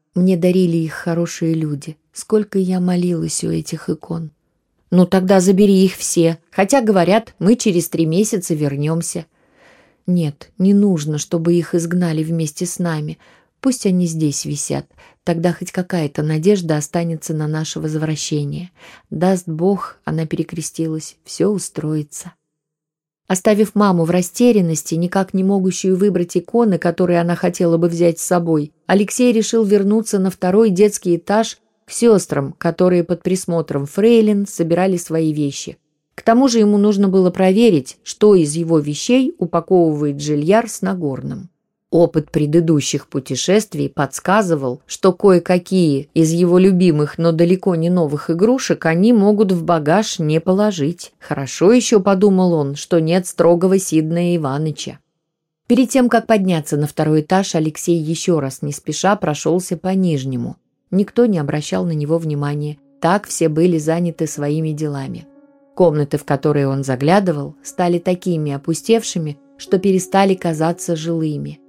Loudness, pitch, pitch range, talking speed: -16 LUFS, 170 Hz, 155-190 Hz, 140 wpm